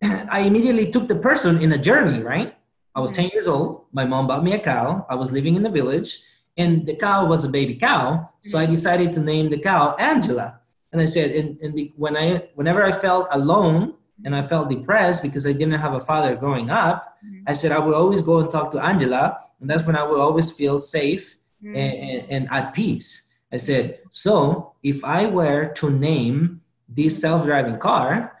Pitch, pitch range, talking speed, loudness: 155 Hz, 140-175 Hz, 210 wpm, -20 LUFS